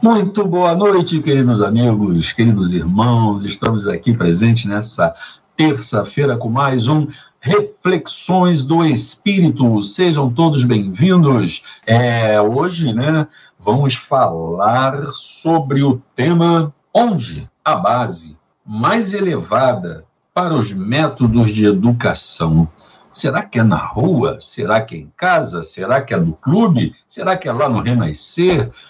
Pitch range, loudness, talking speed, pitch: 110-165 Hz, -15 LUFS, 125 wpm, 135 Hz